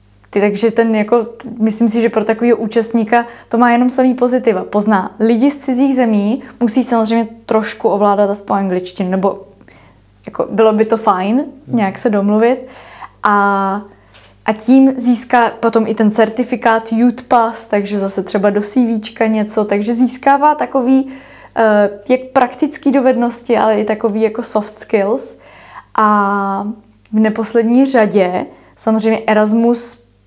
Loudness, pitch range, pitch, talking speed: -14 LUFS, 210-245 Hz, 225 Hz, 135 wpm